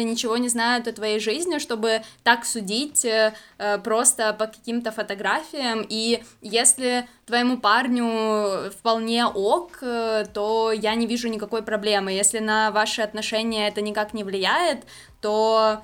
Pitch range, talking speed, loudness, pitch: 215-235 Hz, 130 wpm, -22 LUFS, 220 Hz